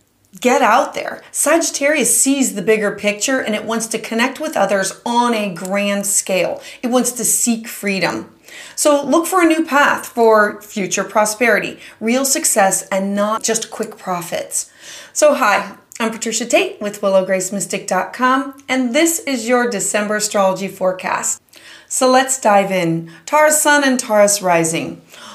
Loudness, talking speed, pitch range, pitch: -16 LUFS, 150 wpm, 200-260 Hz, 220 Hz